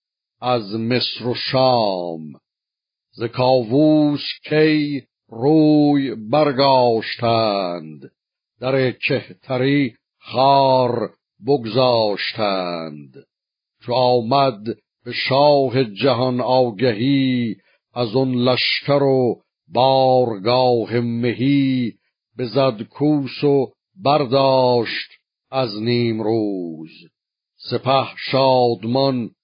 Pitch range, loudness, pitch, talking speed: 115-135 Hz, -18 LUFS, 125 Hz, 70 wpm